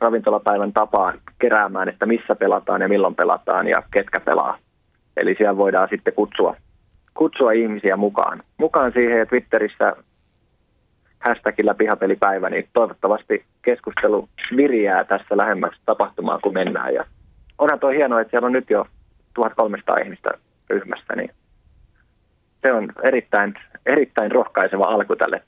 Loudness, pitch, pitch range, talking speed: -19 LUFS, 110 Hz, 100-120 Hz, 130 wpm